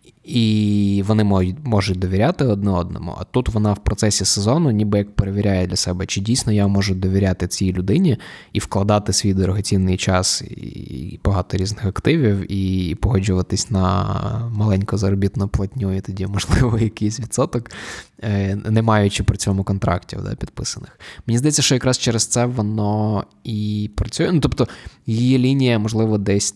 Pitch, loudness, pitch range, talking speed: 100 Hz, -19 LUFS, 95-115 Hz, 150 wpm